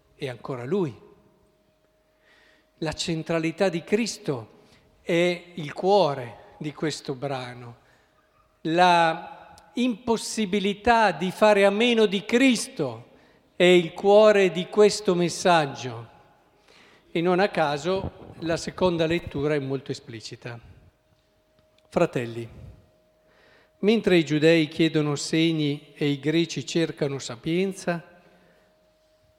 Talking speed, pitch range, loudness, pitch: 100 wpm, 135-185 Hz, -23 LUFS, 165 Hz